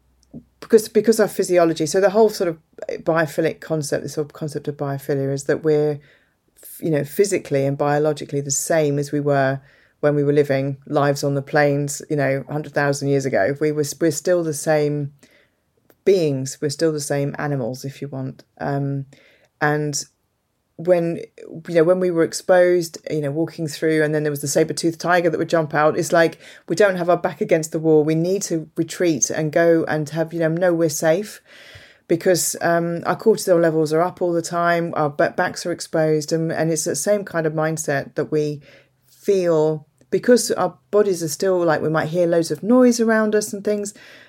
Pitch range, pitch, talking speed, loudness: 145-175 Hz, 160 Hz, 200 wpm, -20 LUFS